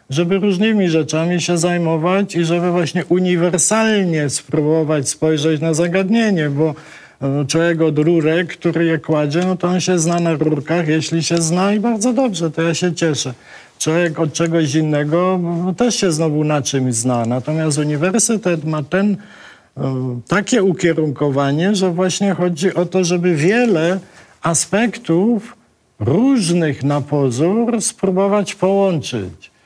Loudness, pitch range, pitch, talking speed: -16 LUFS, 155-185 Hz, 170 Hz, 135 wpm